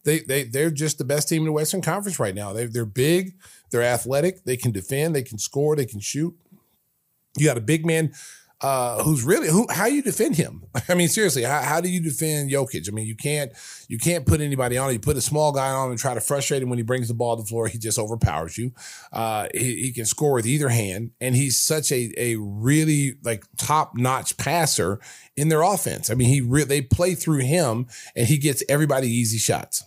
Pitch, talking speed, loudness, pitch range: 135 Hz, 235 wpm, -22 LUFS, 120-155 Hz